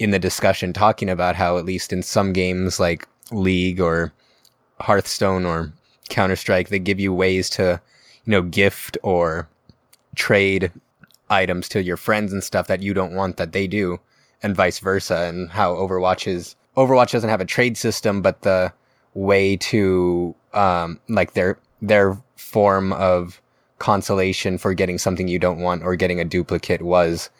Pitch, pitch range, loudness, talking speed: 95 Hz, 90-100 Hz, -20 LUFS, 165 wpm